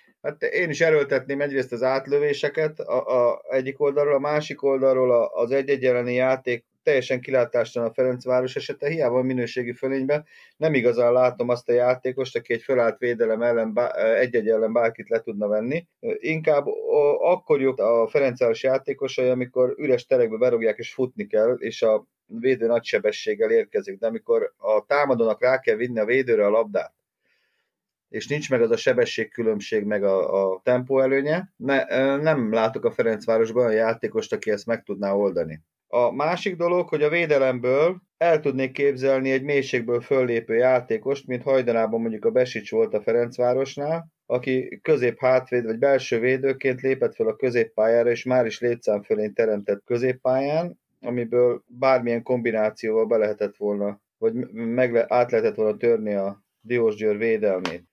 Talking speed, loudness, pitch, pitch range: 155 wpm, -23 LUFS, 130 Hz, 120-170 Hz